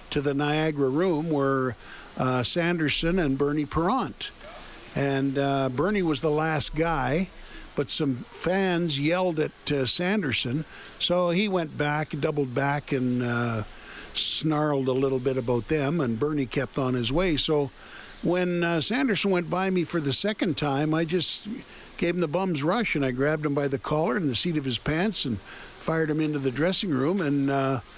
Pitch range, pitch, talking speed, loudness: 135-170 Hz, 150 Hz, 180 wpm, -25 LUFS